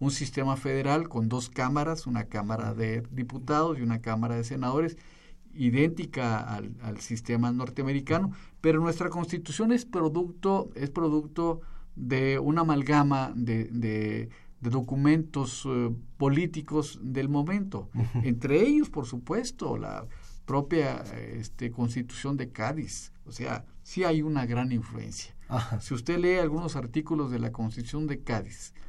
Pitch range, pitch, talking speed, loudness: 120-155 Hz, 135 Hz, 135 wpm, -29 LUFS